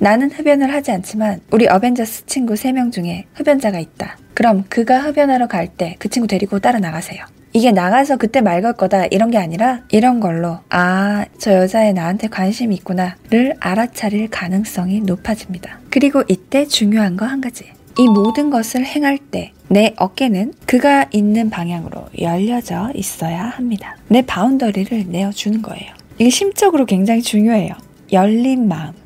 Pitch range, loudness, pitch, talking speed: 190-245 Hz, -15 LUFS, 215 Hz, 350 characters per minute